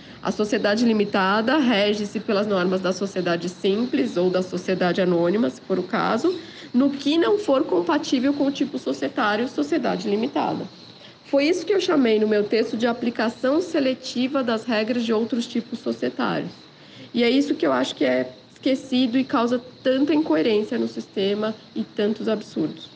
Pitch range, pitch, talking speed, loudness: 200-275 Hz, 230 Hz, 165 wpm, -22 LUFS